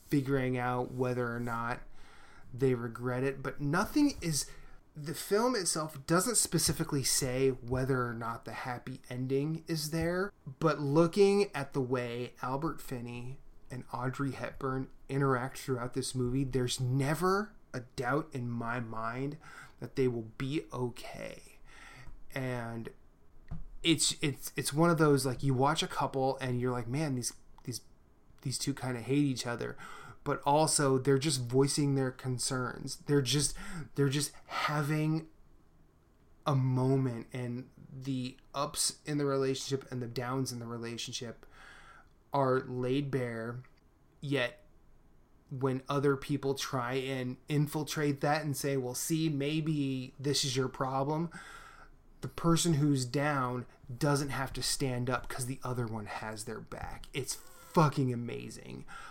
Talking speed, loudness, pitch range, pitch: 145 wpm, -33 LUFS, 125-145 Hz, 135 Hz